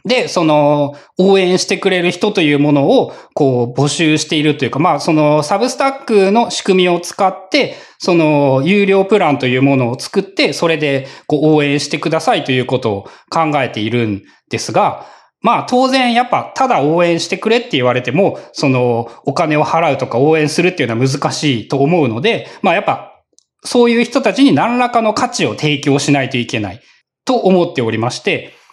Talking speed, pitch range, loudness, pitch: 370 characters per minute, 135-195 Hz, -14 LUFS, 155 Hz